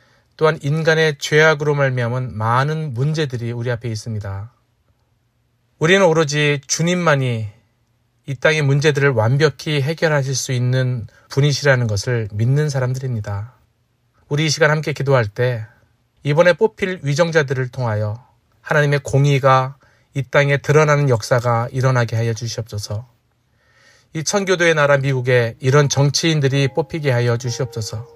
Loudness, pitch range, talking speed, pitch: -17 LUFS, 120-150 Hz, 315 characters per minute, 130 Hz